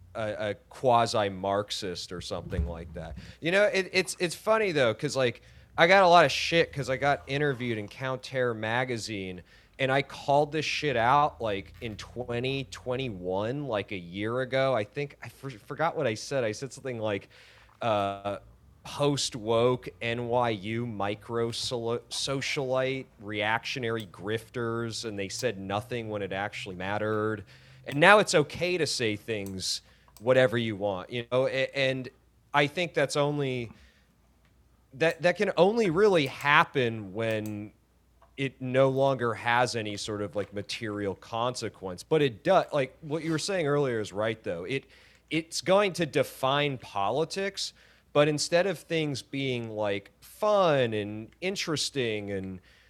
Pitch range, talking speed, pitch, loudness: 105-140 Hz, 150 wpm, 120 Hz, -28 LUFS